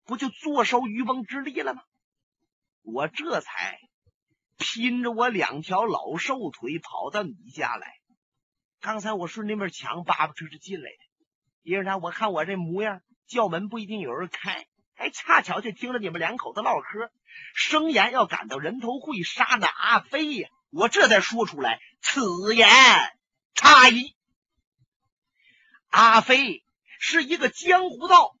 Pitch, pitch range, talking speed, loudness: 240 Hz, 210-280 Hz, 215 characters per minute, -21 LUFS